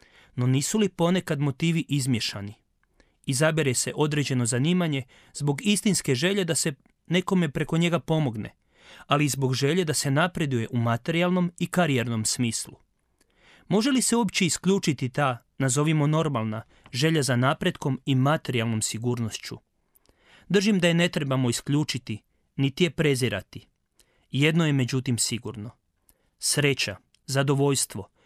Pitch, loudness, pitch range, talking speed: 145 Hz, -25 LUFS, 125-165 Hz, 125 wpm